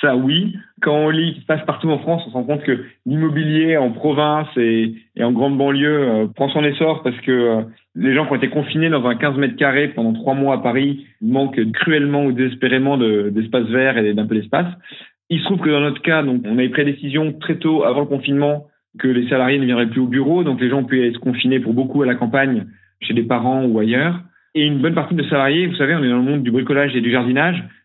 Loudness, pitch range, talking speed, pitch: -17 LUFS, 125-150 Hz, 260 wpm, 140 Hz